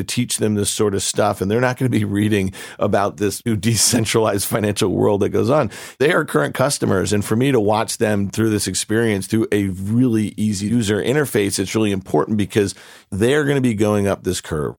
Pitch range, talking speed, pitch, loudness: 100-115 Hz, 225 wpm, 105 Hz, -18 LUFS